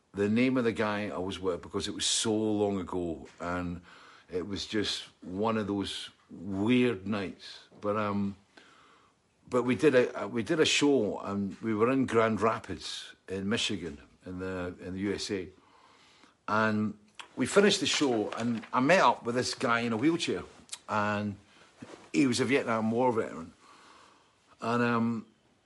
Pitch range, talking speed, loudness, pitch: 100-120 Hz, 165 wpm, -30 LUFS, 110 Hz